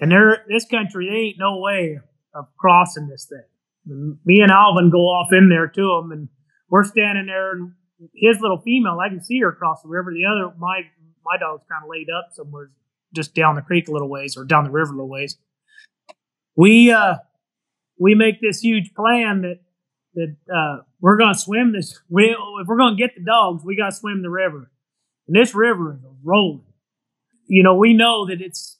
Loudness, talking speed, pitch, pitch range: -16 LUFS, 205 wpm, 180 Hz, 160-205 Hz